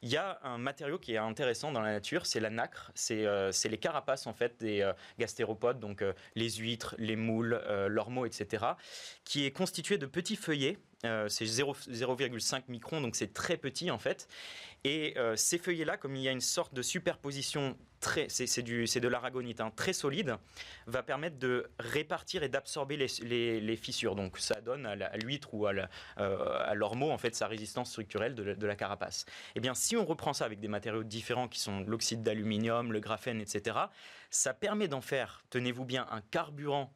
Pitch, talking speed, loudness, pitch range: 125 Hz, 205 wpm, -35 LUFS, 110-140 Hz